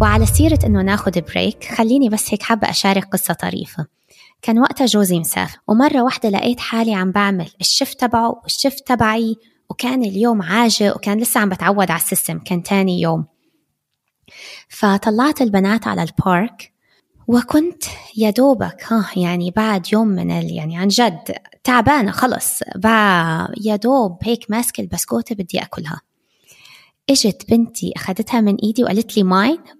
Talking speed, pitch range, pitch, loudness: 145 wpm, 190-240 Hz, 215 Hz, -17 LUFS